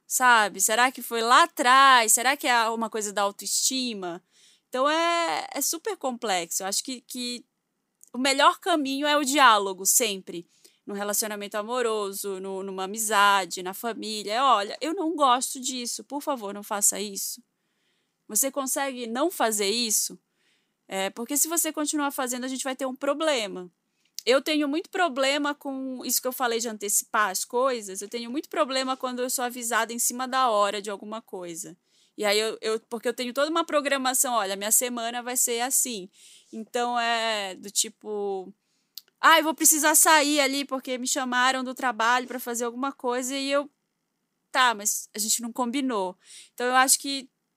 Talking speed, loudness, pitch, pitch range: 175 wpm, -24 LUFS, 245 Hz, 210-270 Hz